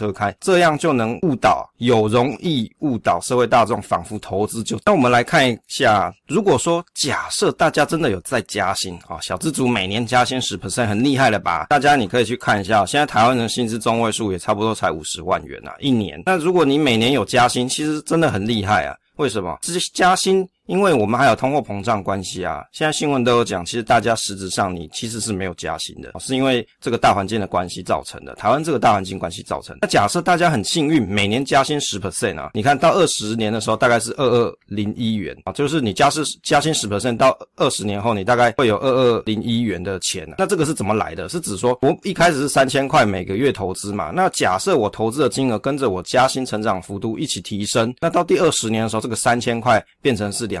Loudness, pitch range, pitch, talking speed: -19 LUFS, 105-140 Hz, 120 Hz, 375 characters per minute